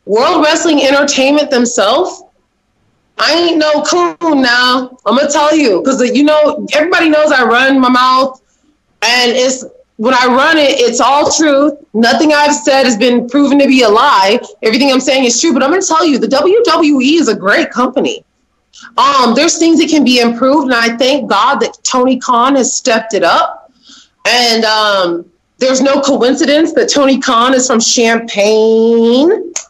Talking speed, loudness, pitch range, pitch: 175 wpm, -9 LUFS, 245-300 Hz, 265 Hz